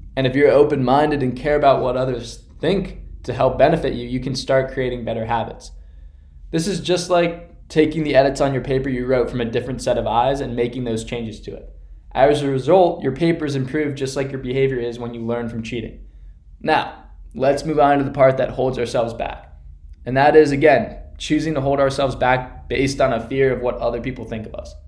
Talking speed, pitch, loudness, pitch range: 220 wpm, 130 Hz, -19 LUFS, 115-140 Hz